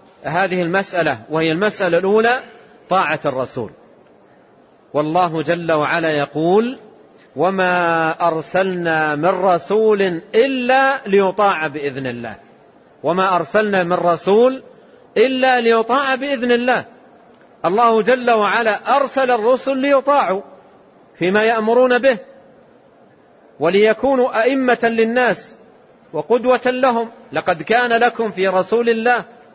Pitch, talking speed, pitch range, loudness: 215 Hz, 95 wpm, 175-245 Hz, -16 LUFS